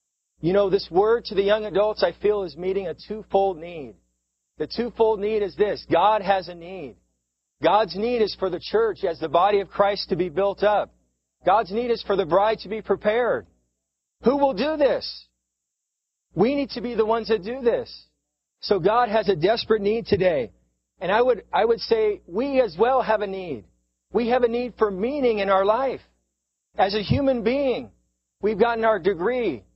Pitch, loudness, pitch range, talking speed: 205 Hz, -23 LUFS, 175-235 Hz, 195 wpm